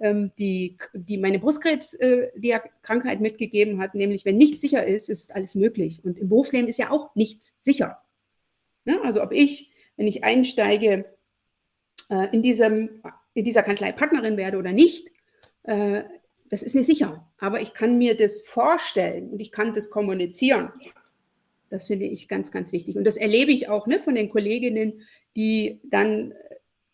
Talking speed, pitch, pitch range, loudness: 155 wpm, 220 Hz, 205-255 Hz, -23 LUFS